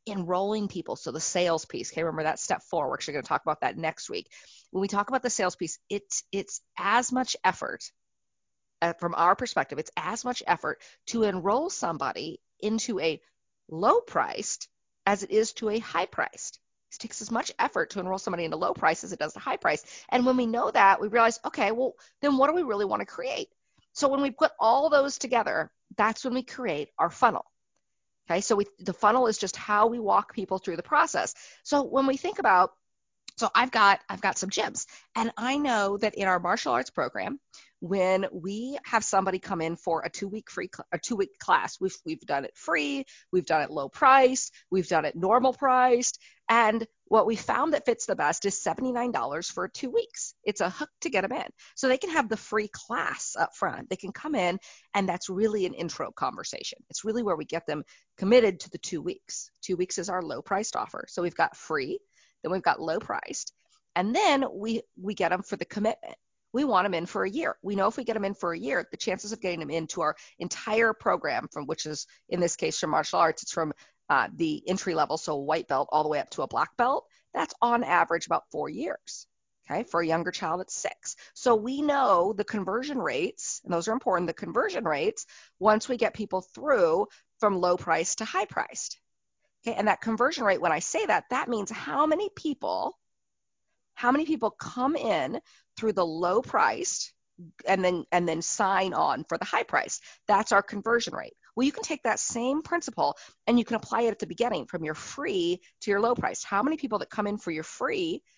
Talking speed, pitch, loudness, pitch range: 220 wpm, 215 Hz, -28 LUFS, 185-255 Hz